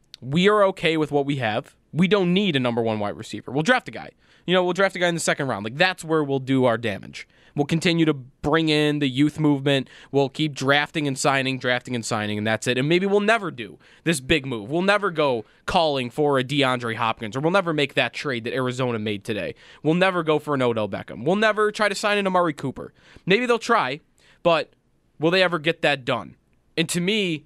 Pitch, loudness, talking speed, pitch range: 150 Hz, -22 LUFS, 240 wpm, 125-175 Hz